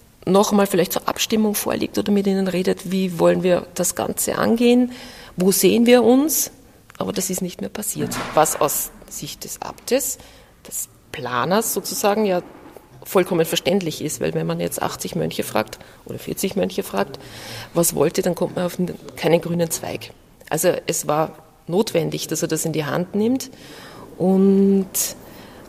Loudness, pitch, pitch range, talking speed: -20 LUFS, 190 Hz, 170-210 Hz, 165 wpm